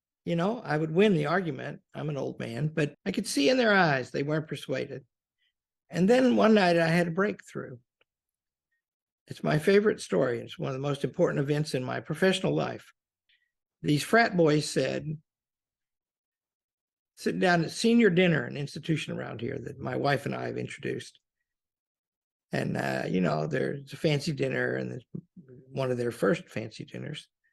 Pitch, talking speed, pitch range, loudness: 160 Hz, 170 wpm, 140-195 Hz, -28 LUFS